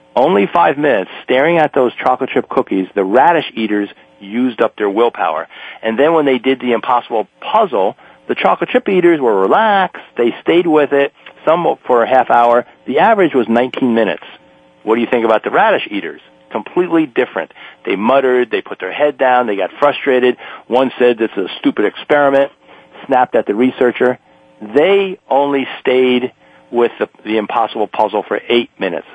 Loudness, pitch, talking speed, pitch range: -14 LUFS, 125 Hz, 175 wpm, 110-140 Hz